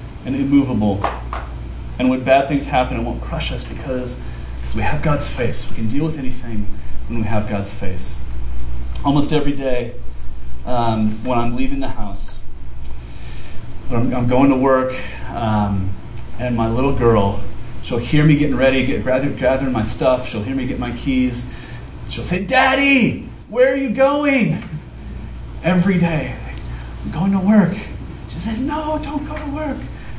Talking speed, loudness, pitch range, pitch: 165 wpm, -19 LUFS, 105-140 Hz, 125 Hz